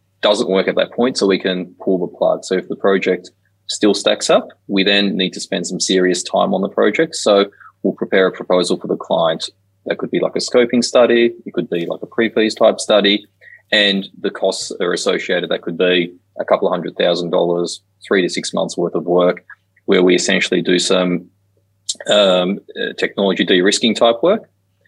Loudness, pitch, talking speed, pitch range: -16 LUFS, 95 Hz, 205 wpm, 90-105 Hz